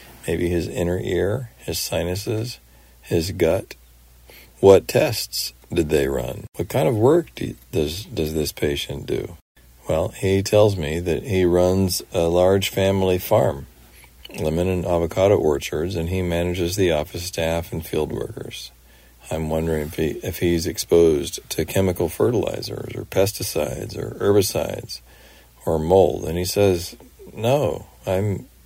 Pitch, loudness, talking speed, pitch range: 85 Hz, -21 LUFS, 145 wpm, 75-95 Hz